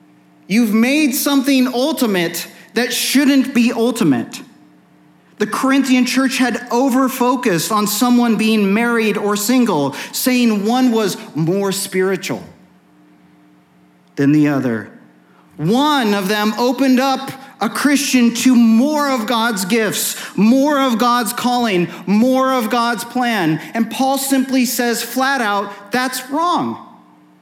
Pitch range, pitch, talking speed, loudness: 195-255 Hz, 235 Hz, 120 wpm, -16 LUFS